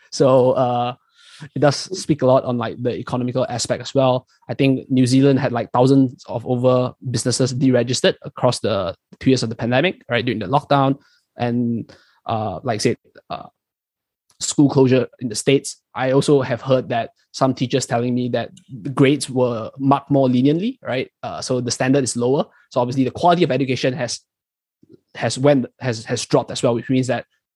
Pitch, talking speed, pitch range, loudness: 130 Hz, 190 wpm, 120-135 Hz, -19 LUFS